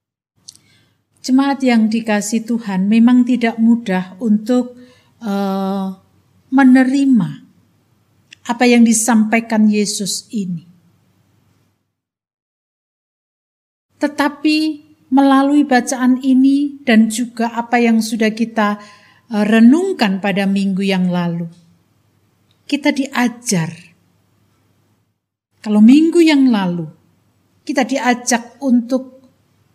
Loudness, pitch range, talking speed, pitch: -15 LUFS, 180-255 Hz, 80 wpm, 225 Hz